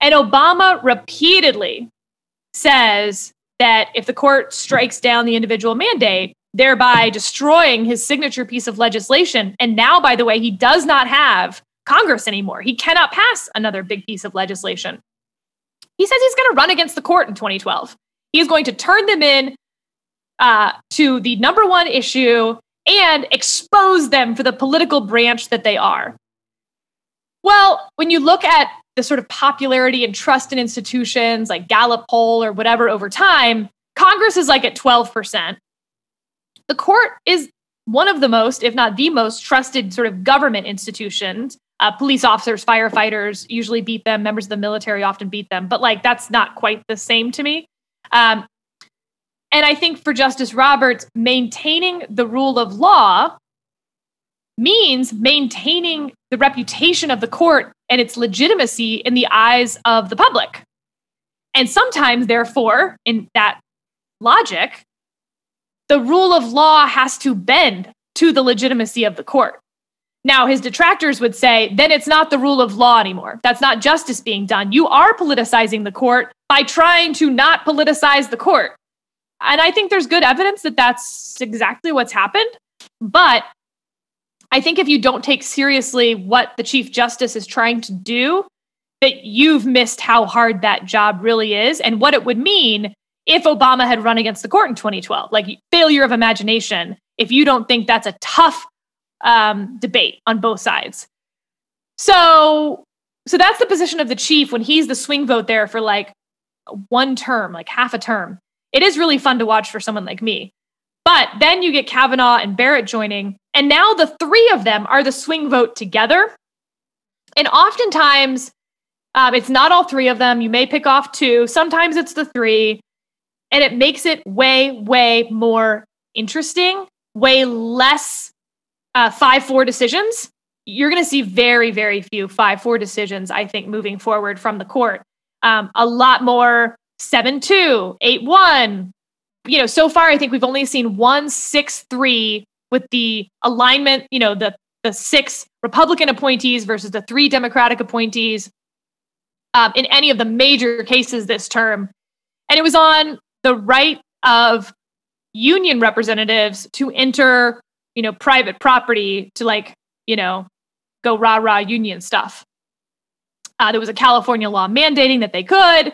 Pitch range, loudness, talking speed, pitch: 225-285 Hz, -14 LUFS, 165 wpm, 245 Hz